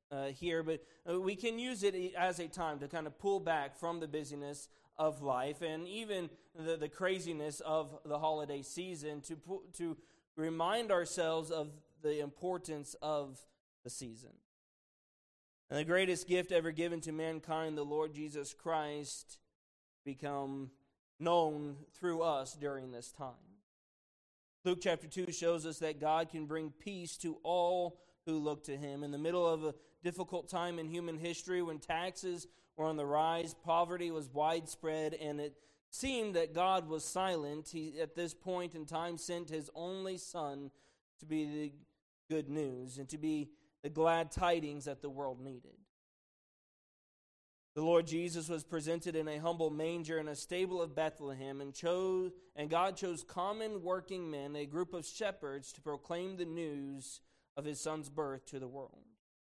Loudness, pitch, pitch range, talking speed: -39 LUFS, 160 Hz, 150-175 Hz, 165 wpm